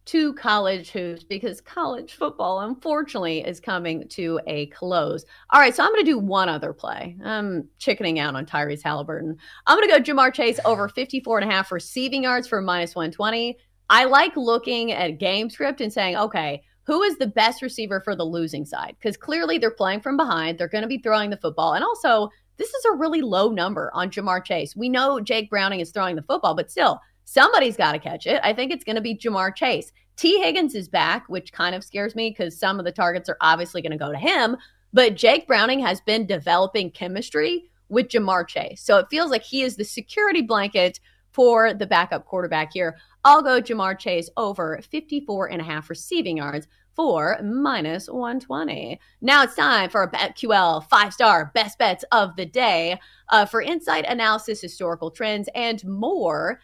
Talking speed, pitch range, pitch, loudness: 200 wpm, 175-245 Hz, 210 Hz, -21 LUFS